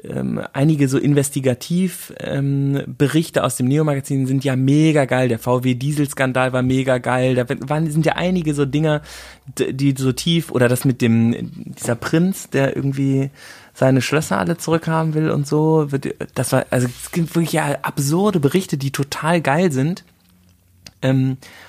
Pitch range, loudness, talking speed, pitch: 130-160 Hz, -19 LUFS, 155 wpm, 140 Hz